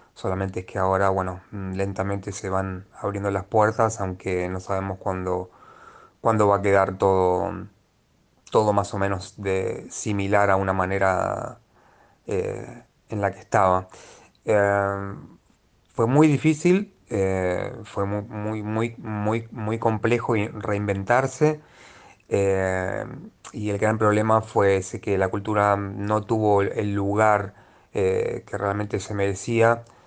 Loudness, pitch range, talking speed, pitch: -24 LUFS, 95-110 Hz, 130 wpm, 100 Hz